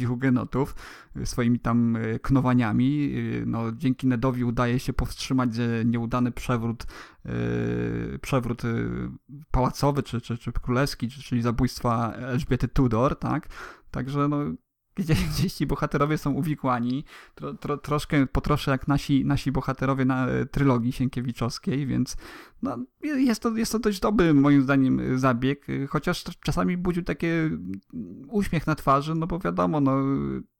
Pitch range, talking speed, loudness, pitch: 120-145 Hz, 125 wpm, -26 LUFS, 130 Hz